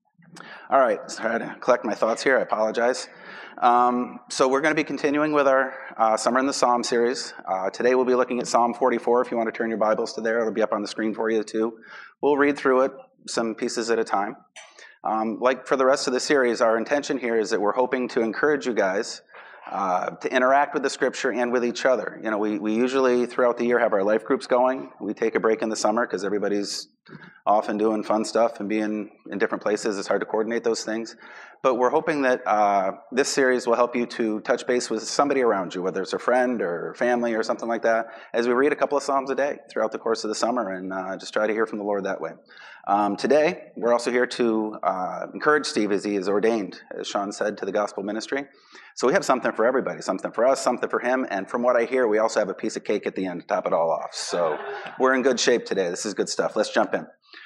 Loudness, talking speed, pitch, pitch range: -23 LUFS, 255 wpm, 120 Hz, 110-130 Hz